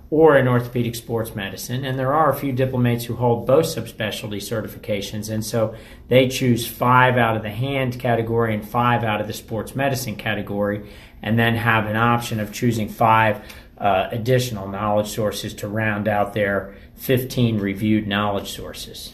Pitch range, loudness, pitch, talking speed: 105-120 Hz, -21 LUFS, 110 Hz, 170 wpm